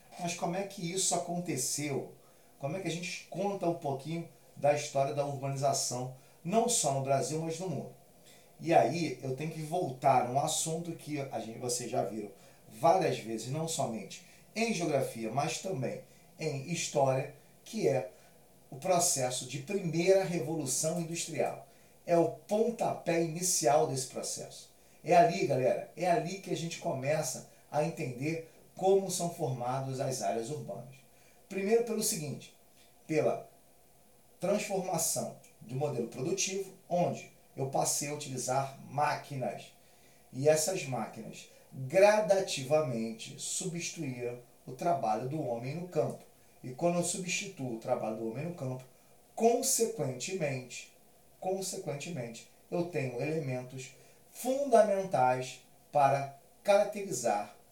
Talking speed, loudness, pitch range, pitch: 130 wpm, -32 LUFS, 135-180 Hz, 160 Hz